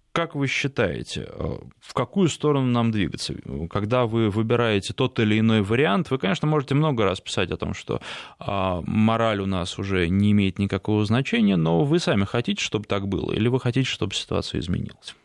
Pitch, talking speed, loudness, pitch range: 110 Hz, 175 wpm, -23 LUFS, 100-130 Hz